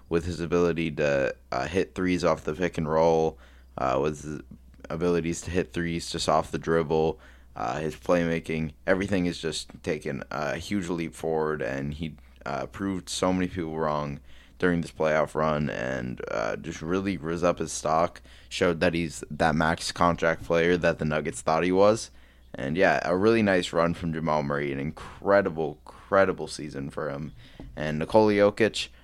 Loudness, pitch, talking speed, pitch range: -27 LUFS, 80 Hz, 175 wpm, 75-90 Hz